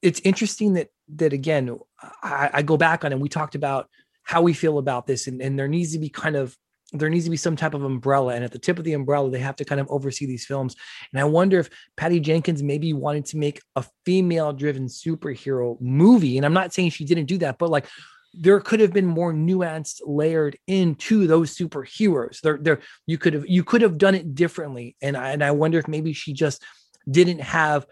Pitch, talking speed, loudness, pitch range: 155 Hz, 230 wpm, -22 LUFS, 140-170 Hz